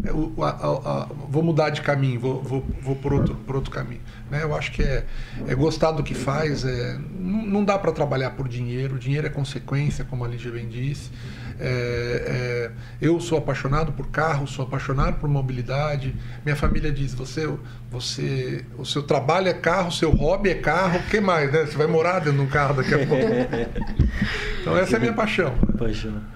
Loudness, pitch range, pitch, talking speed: -24 LUFS, 125-155 Hz, 140 Hz, 160 wpm